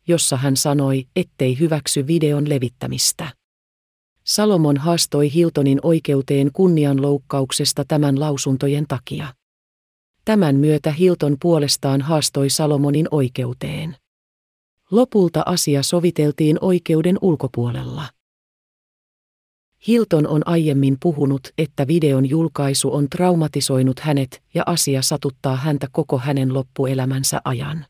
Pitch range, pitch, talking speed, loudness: 135-160 Hz, 145 Hz, 95 wpm, -18 LUFS